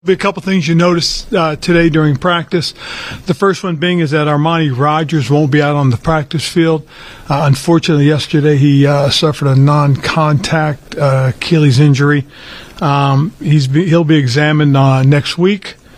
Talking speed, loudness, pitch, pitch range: 170 wpm, -12 LUFS, 150 Hz, 145-170 Hz